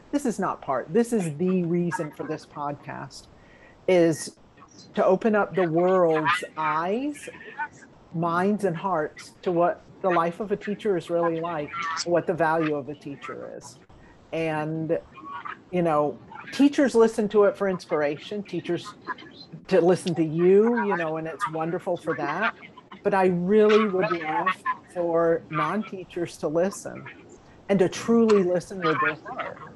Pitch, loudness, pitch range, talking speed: 180 Hz, -25 LUFS, 165-205 Hz, 150 wpm